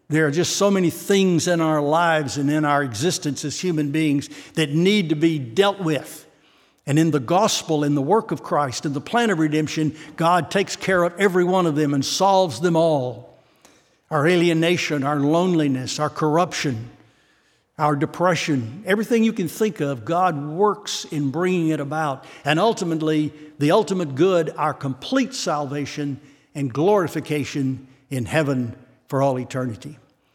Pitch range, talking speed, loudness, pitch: 145-180 Hz, 160 wpm, -21 LUFS, 155 Hz